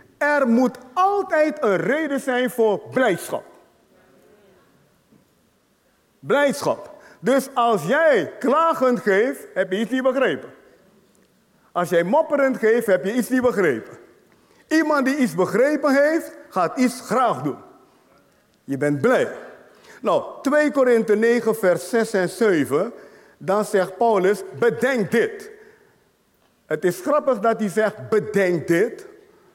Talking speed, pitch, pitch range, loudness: 125 wpm, 250 Hz, 210-295 Hz, -20 LUFS